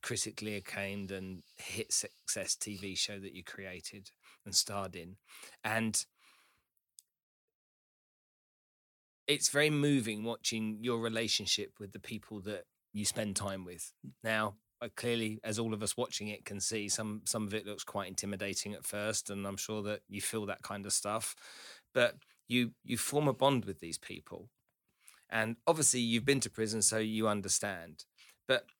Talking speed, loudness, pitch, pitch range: 160 wpm, -34 LUFS, 110 Hz, 100-115 Hz